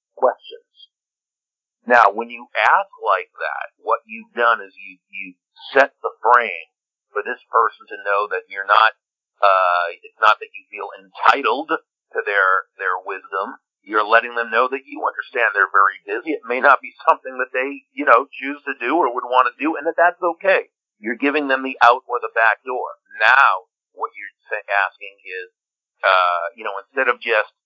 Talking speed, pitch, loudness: 190 wpm, 160 Hz, -18 LUFS